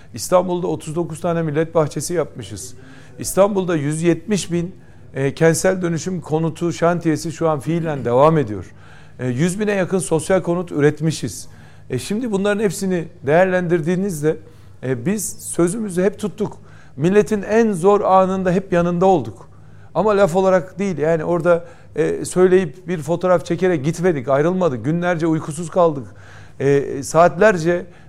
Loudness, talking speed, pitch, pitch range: -18 LUFS, 130 wpm, 170 Hz, 155-185 Hz